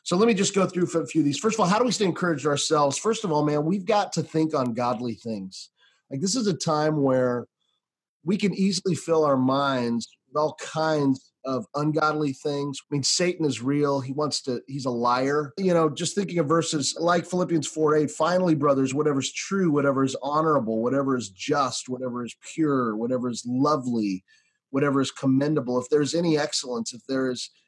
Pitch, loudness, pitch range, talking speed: 150 Hz, -24 LUFS, 130-165 Hz, 210 wpm